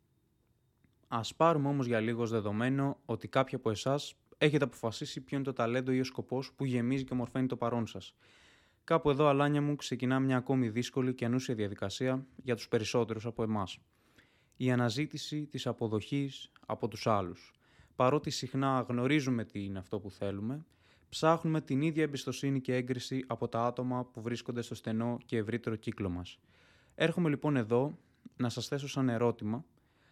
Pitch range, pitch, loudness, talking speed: 115-135 Hz, 125 Hz, -34 LUFS, 165 wpm